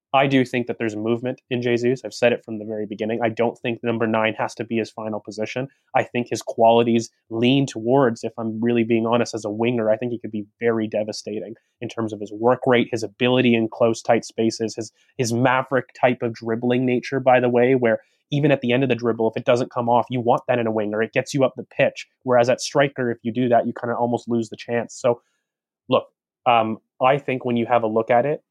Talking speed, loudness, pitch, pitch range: 255 wpm, -21 LUFS, 120 Hz, 115-125 Hz